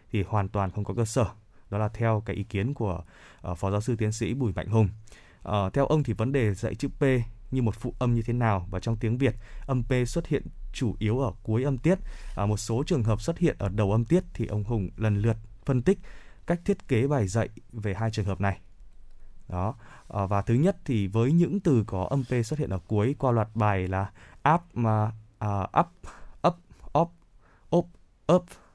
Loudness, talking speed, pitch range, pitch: -28 LUFS, 230 wpm, 100-130 Hz, 110 Hz